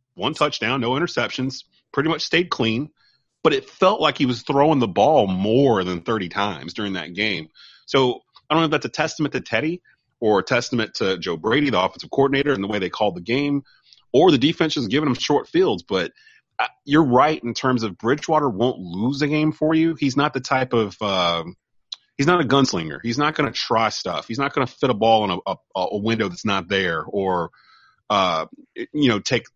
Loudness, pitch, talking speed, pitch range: -21 LUFS, 135 Hz, 215 wpm, 110-155 Hz